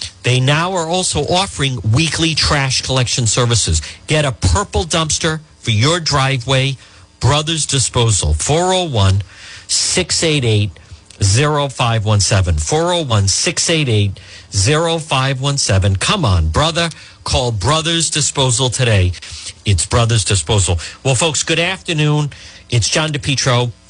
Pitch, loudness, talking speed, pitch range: 125 Hz, -15 LUFS, 105 wpm, 100-150 Hz